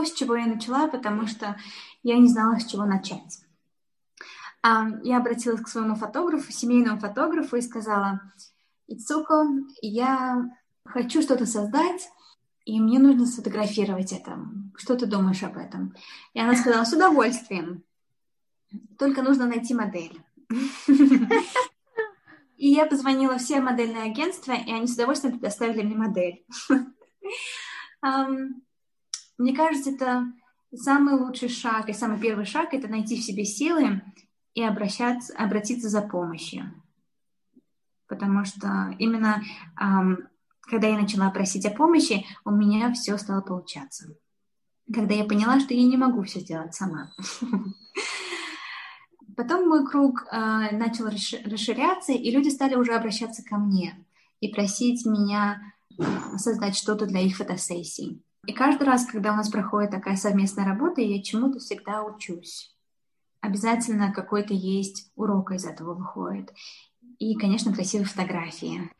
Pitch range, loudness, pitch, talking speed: 200-255 Hz, -25 LUFS, 225 Hz, 130 wpm